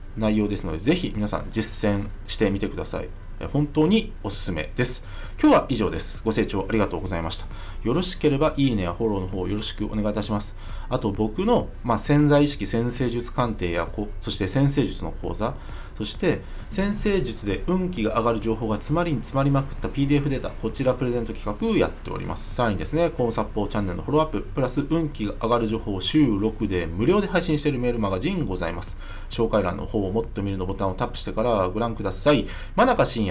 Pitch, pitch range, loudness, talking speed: 110 Hz, 100-130 Hz, -24 LUFS, 445 characters per minute